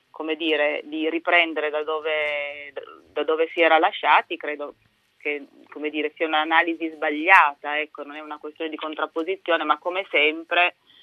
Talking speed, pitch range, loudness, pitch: 150 wpm, 150-165 Hz, -22 LUFS, 155 Hz